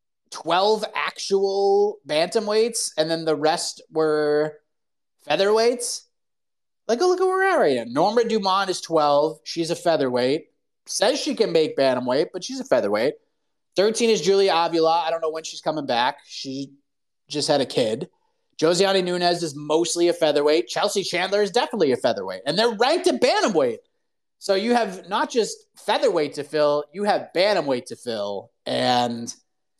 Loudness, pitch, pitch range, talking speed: -22 LUFS, 180 Hz, 155-240 Hz, 165 wpm